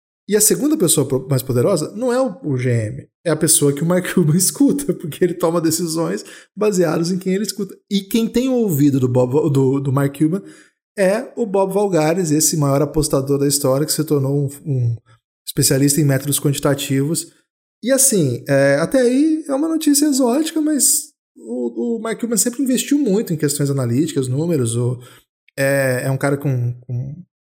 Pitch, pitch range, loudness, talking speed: 155 Hz, 140-210 Hz, -17 LUFS, 185 wpm